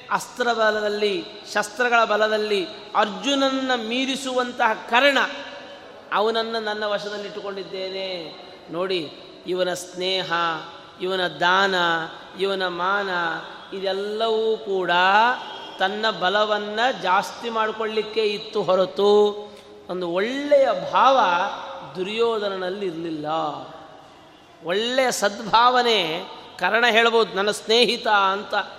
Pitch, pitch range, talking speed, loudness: 205 Hz, 185-225 Hz, 75 wpm, -22 LUFS